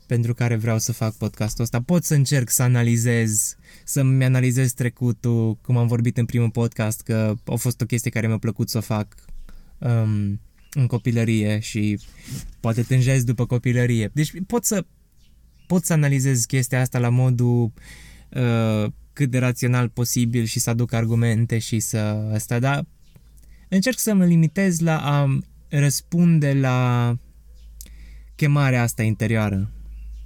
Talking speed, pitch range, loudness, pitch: 145 wpm, 110-130 Hz, -21 LUFS, 120 Hz